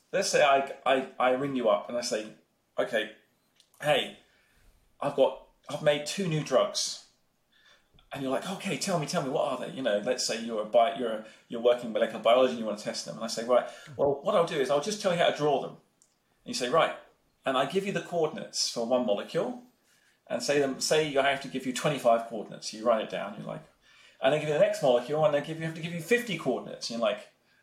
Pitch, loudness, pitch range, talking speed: 145 Hz, -28 LUFS, 125-160 Hz, 255 wpm